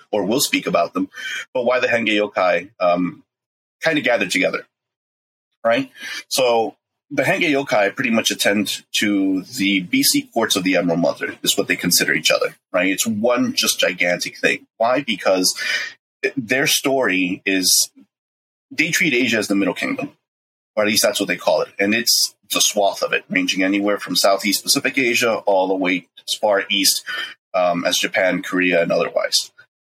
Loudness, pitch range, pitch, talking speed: -18 LUFS, 90-125 Hz, 100 Hz, 175 wpm